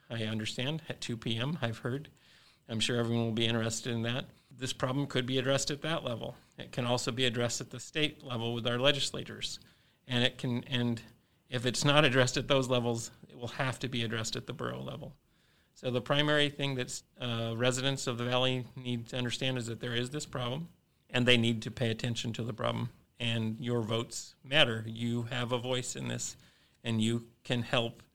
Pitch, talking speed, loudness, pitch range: 125 Hz, 210 wpm, -32 LUFS, 115-135 Hz